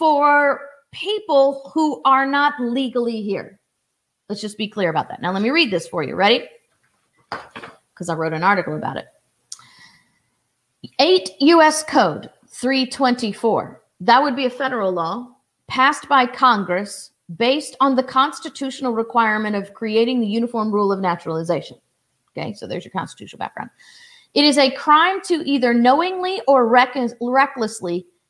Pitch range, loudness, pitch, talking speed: 215-280 Hz, -18 LUFS, 255 Hz, 145 wpm